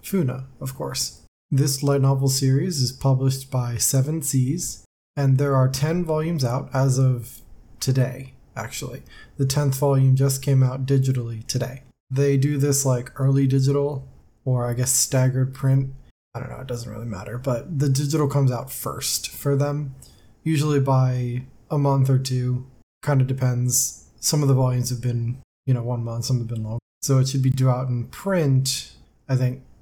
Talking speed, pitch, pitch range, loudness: 180 wpm, 130 Hz, 125-140 Hz, -22 LUFS